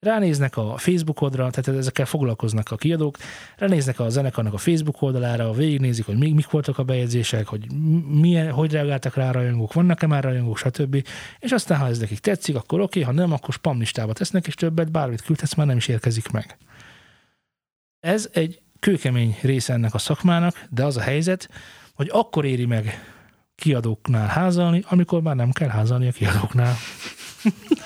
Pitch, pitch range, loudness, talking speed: 140 Hz, 120-165 Hz, -22 LUFS, 170 wpm